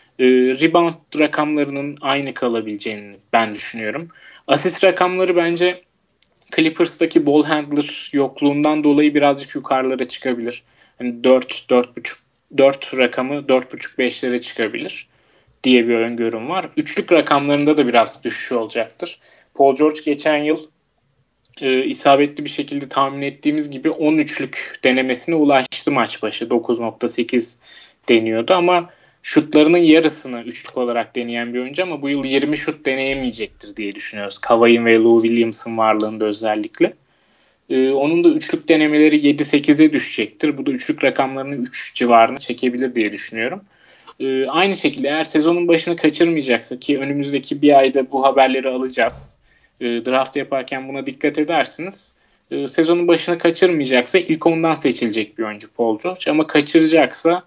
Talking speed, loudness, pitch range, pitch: 130 wpm, -17 LUFS, 125-155 Hz, 140 Hz